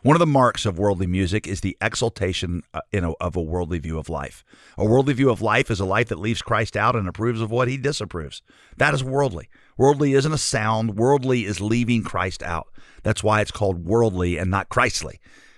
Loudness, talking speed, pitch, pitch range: -22 LUFS, 210 wpm, 110 Hz, 95-125 Hz